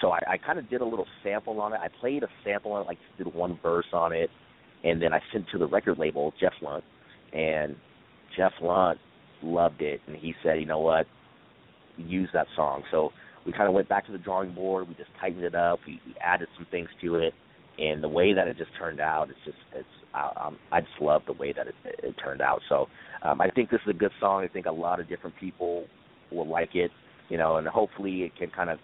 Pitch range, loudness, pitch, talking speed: 80-95 Hz, -29 LUFS, 85 Hz, 250 wpm